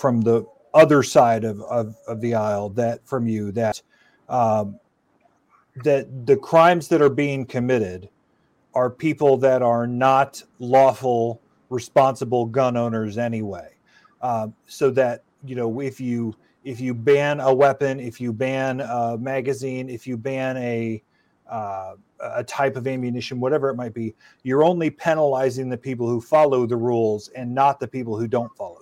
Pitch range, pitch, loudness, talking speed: 115-135 Hz, 125 Hz, -21 LUFS, 160 wpm